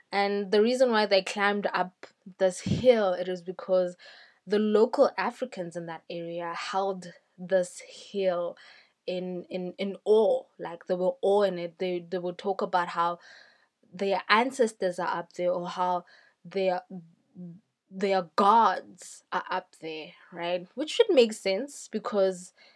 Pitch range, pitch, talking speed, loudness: 180-205 Hz, 185 Hz, 150 wpm, -28 LUFS